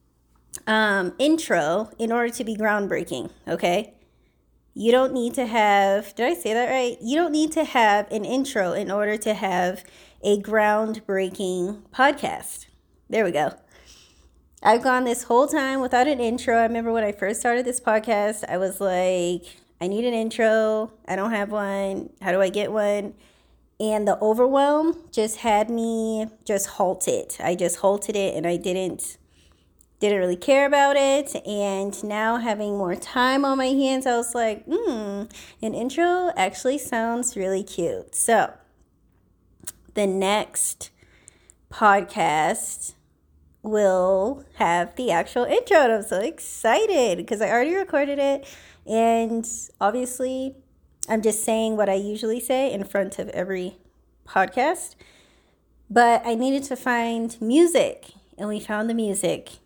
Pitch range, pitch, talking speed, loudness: 195-250 Hz, 220 Hz, 150 wpm, -23 LUFS